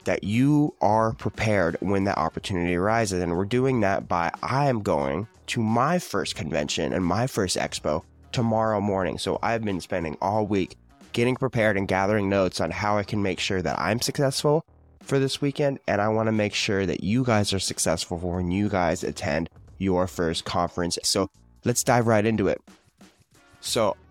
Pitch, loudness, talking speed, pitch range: 100 Hz, -25 LUFS, 185 wpm, 90-115 Hz